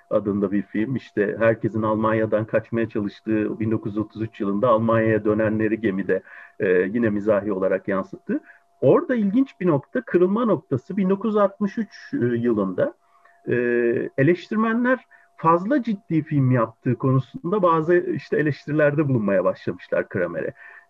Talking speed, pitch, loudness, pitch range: 105 wpm, 120 Hz, -22 LUFS, 110-180 Hz